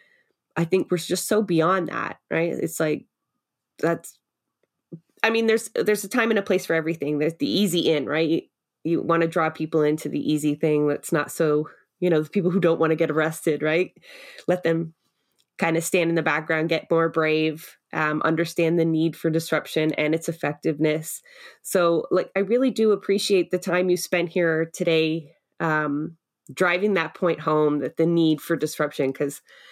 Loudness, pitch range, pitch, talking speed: -23 LUFS, 155-180 Hz, 165 Hz, 190 wpm